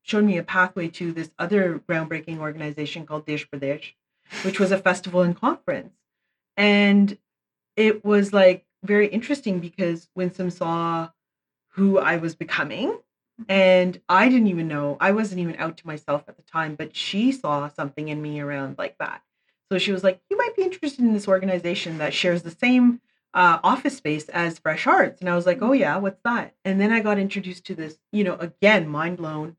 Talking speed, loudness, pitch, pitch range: 195 wpm, -22 LUFS, 180 Hz, 160-205 Hz